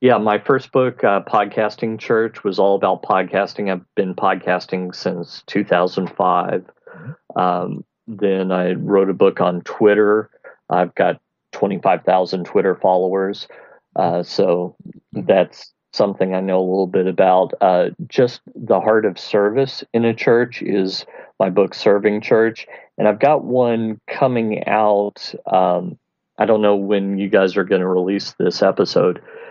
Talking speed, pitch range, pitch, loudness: 145 wpm, 95-110 Hz, 100 Hz, -18 LUFS